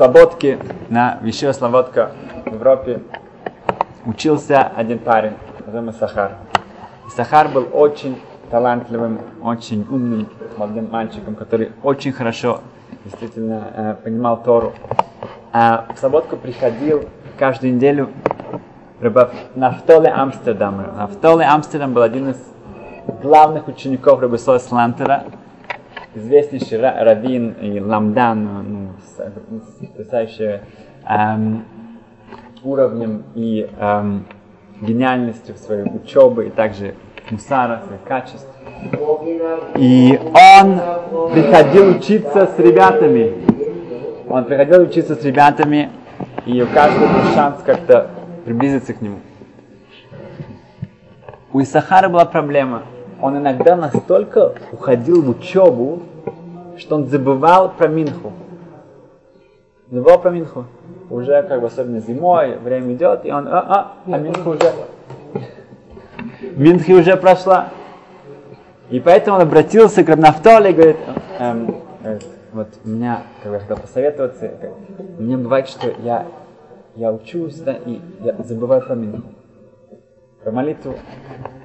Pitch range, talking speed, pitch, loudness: 115-165 Hz, 110 wpm, 130 Hz, -14 LUFS